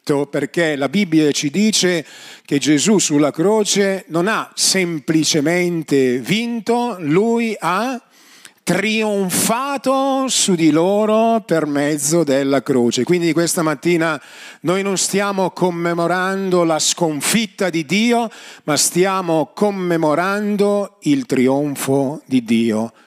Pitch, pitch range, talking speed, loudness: 175 Hz, 150-200 Hz, 105 wpm, -17 LUFS